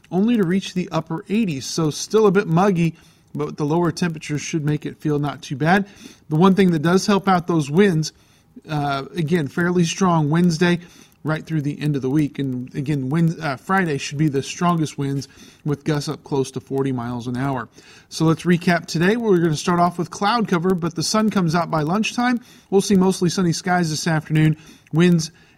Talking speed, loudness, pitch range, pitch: 210 wpm, -20 LUFS, 150-180 Hz, 165 Hz